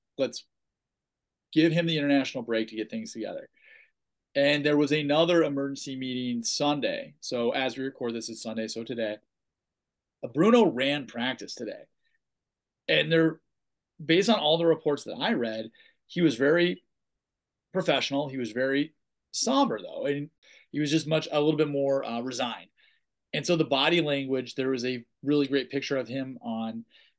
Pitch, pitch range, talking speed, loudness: 140 Hz, 125-155 Hz, 165 wpm, -27 LUFS